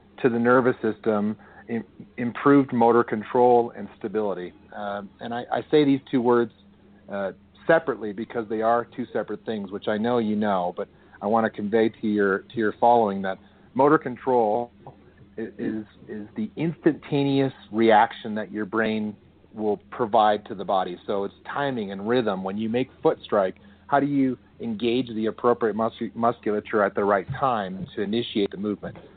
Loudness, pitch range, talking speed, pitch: -24 LUFS, 105-120 Hz, 170 wpm, 115 Hz